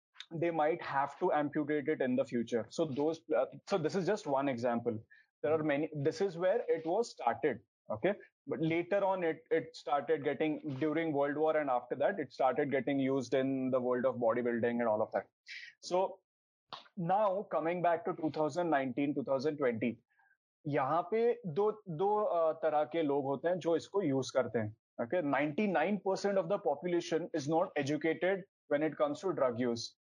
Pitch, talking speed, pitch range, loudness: 155 Hz, 150 wpm, 140-180 Hz, -34 LUFS